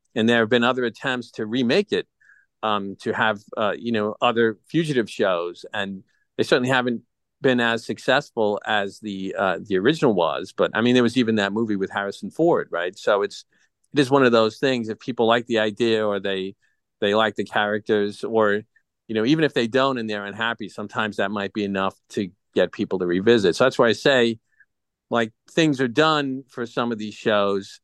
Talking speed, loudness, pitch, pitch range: 205 wpm, -22 LUFS, 110 Hz, 105-120 Hz